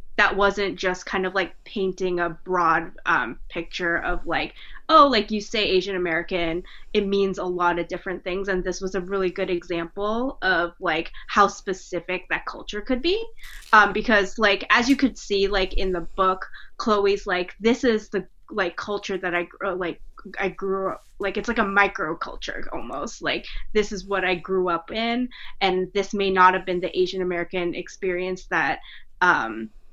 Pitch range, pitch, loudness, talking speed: 180-205 Hz, 190 Hz, -23 LUFS, 185 wpm